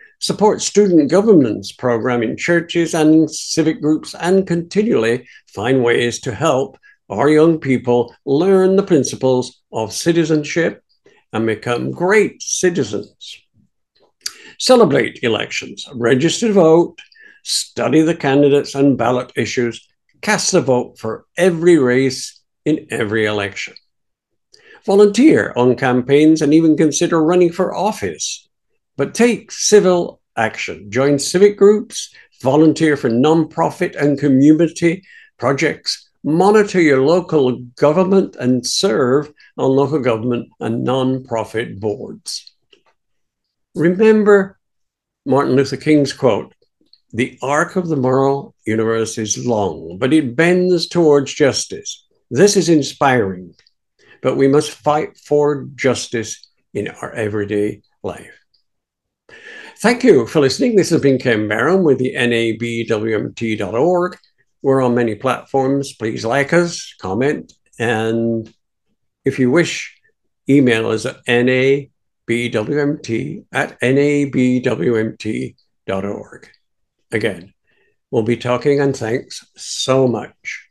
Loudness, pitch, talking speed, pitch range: -16 LUFS, 140 Hz, 110 wpm, 120-175 Hz